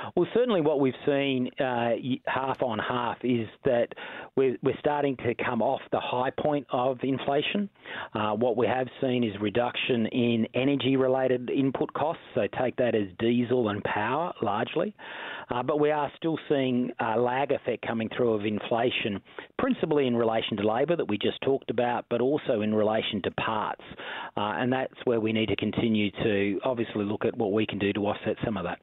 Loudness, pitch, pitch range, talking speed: -28 LUFS, 125 Hz, 110-135 Hz, 190 wpm